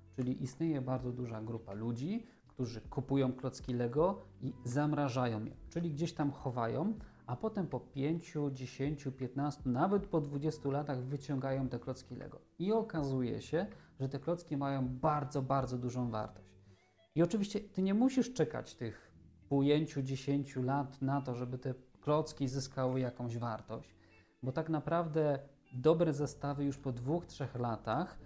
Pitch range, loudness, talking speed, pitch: 125-150 Hz, -37 LUFS, 145 wpm, 135 Hz